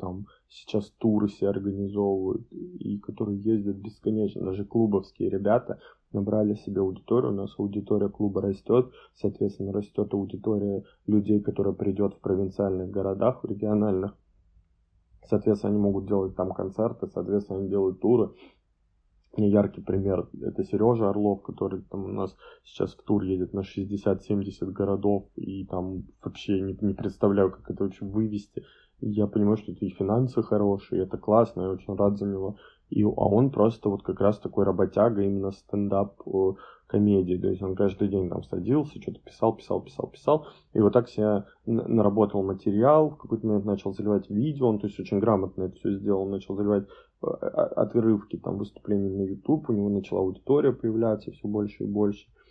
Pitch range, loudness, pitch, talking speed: 95-105 Hz, -27 LUFS, 100 Hz, 160 wpm